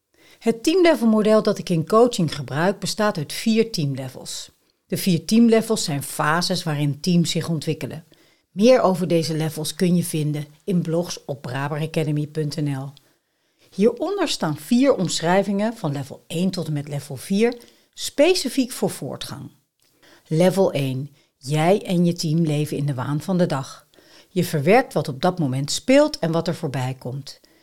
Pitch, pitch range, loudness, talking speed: 170 Hz, 150-205 Hz, -21 LUFS, 155 wpm